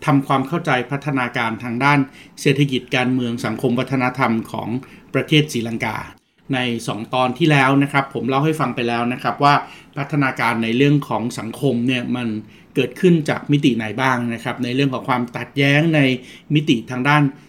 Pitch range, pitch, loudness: 120-145 Hz, 130 Hz, -19 LUFS